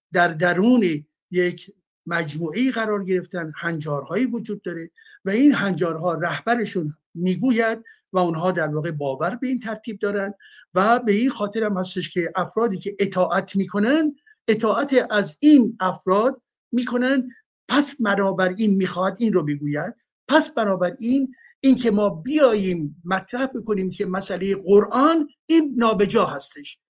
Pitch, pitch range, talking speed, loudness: 200 Hz, 180-240 Hz, 135 wpm, -21 LUFS